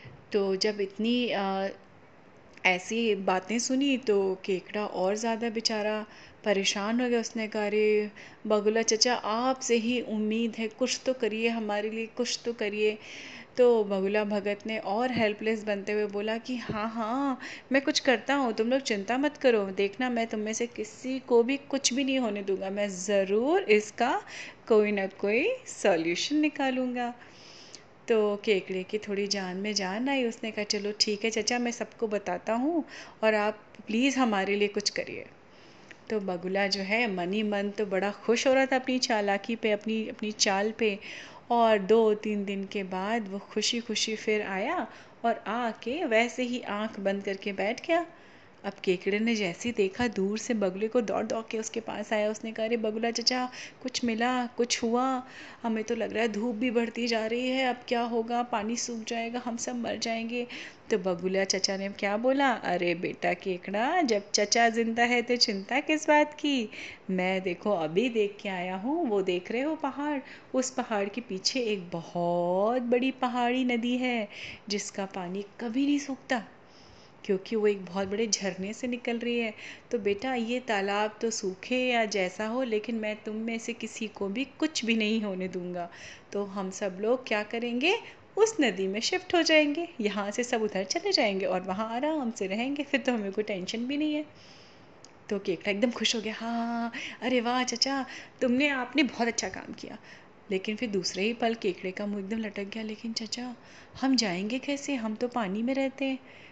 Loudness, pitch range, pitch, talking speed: -29 LUFS, 205-245 Hz, 225 Hz, 185 wpm